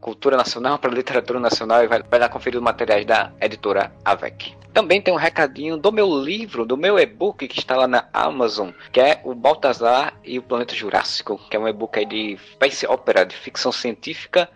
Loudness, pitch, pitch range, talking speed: -20 LUFS, 120 Hz, 115-160 Hz, 195 wpm